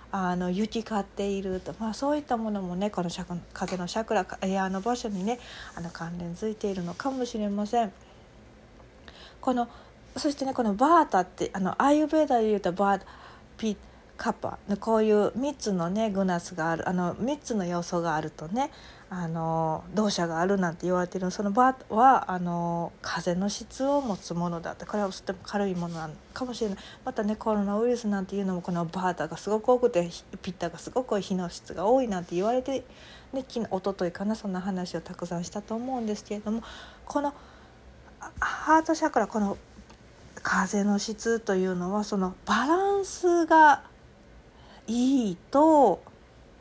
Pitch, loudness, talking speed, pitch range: 205 Hz, -28 LUFS, 340 characters per minute, 180-240 Hz